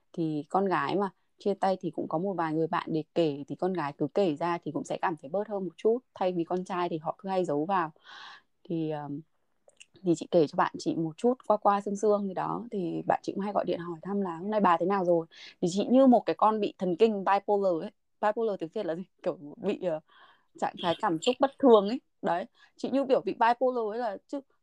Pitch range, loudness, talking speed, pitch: 165-210 Hz, -29 LUFS, 260 wpm, 185 Hz